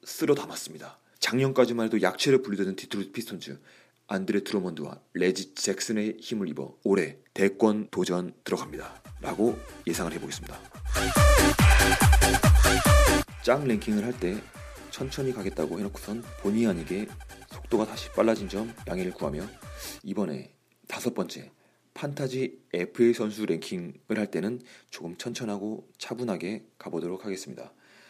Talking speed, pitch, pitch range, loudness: 310 characters per minute, 110 Hz, 95-130 Hz, -27 LUFS